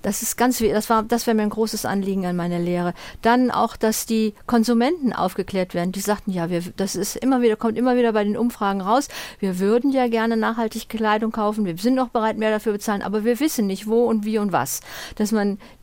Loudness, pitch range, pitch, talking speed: -21 LUFS, 200-235 Hz, 215 Hz, 235 wpm